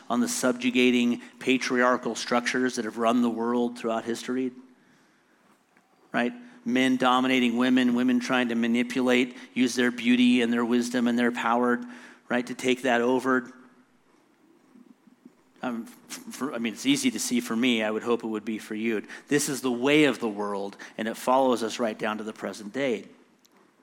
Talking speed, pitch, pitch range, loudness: 175 wpm, 125 Hz, 120-130 Hz, -26 LUFS